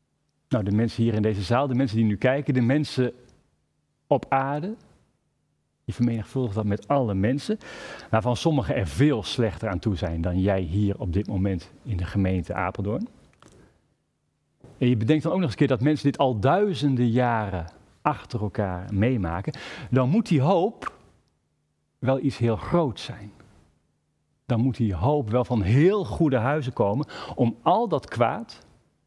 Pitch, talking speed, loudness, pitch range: 120 Hz, 165 wpm, -25 LUFS, 100-140 Hz